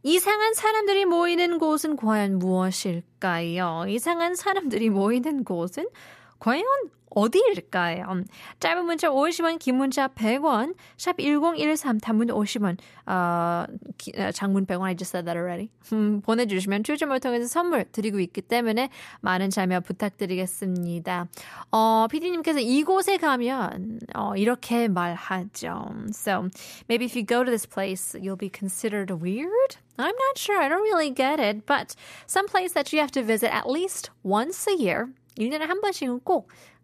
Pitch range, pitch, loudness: 195-310 Hz, 230 Hz, -25 LUFS